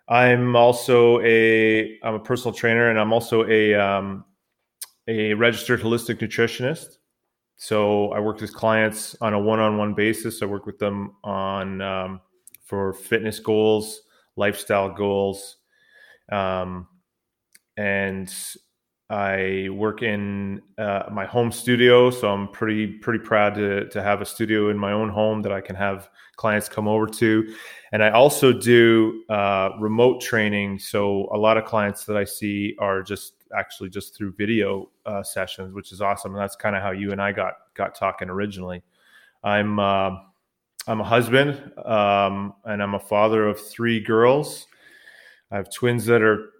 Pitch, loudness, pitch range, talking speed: 105 Hz, -21 LUFS, 100-110 Hz, 160 wpm